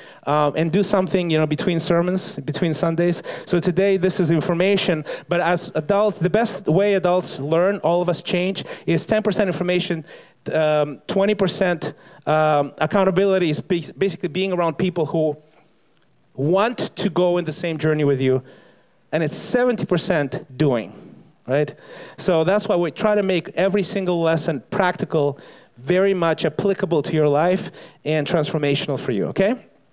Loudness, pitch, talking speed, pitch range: -20 LUFS, 175 Hz, 155 wpm, 155-190 Hz